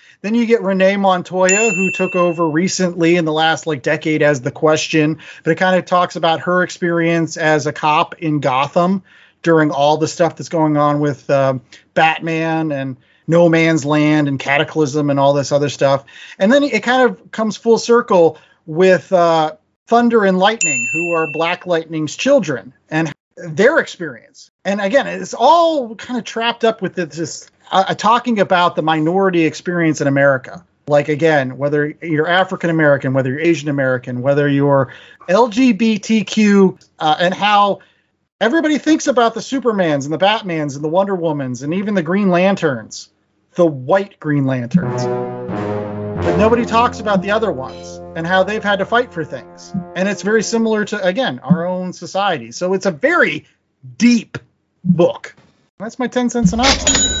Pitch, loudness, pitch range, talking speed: 170 Hz, -15 LUFS, 150-195 Hz, 170 wpm